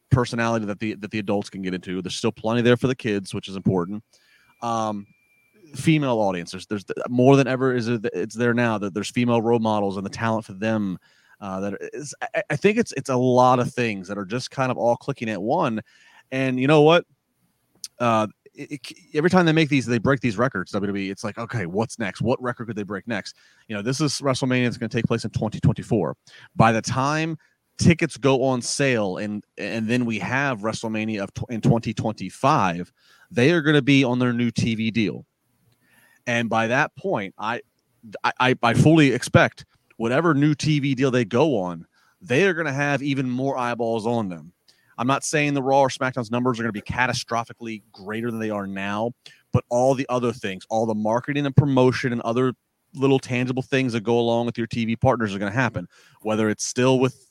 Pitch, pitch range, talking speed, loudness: 120 Hz, 110-135 Hz, 215 wpm, -22 LUFS